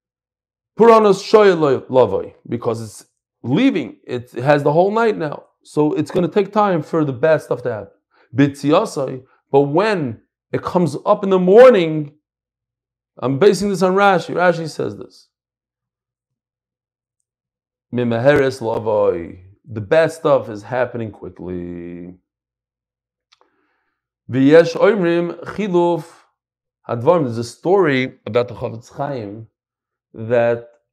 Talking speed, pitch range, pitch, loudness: 100 wpm, 120-175 Hz, 135 Hz, -16 LUFS